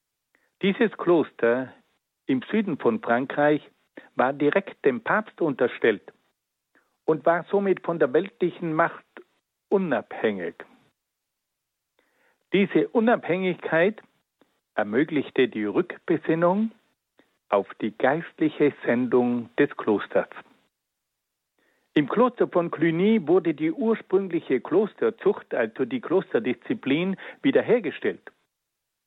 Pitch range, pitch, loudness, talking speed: 150-225 Hz, 180 Hz, -24 LUFS, 85 wpm